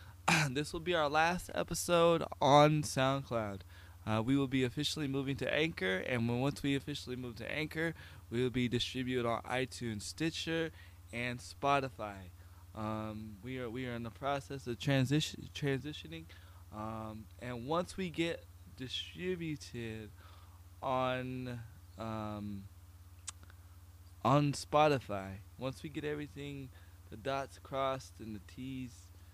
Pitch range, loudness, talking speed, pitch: 95-140 Hz, -36 LUFS, 130 wpm, 120 Hz